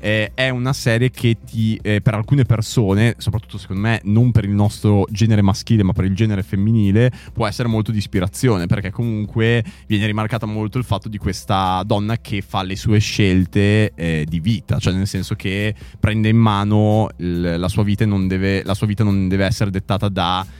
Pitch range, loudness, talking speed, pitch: 95-115 Hz, -18 LUFS, 185 wpm, 105 Hz